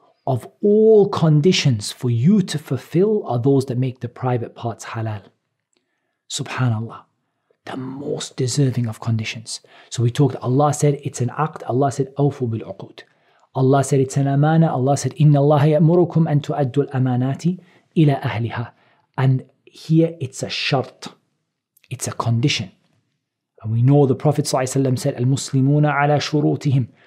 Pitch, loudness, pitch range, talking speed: 140 Hz, -19 LUFS, 125-150 Hz, 145 wpm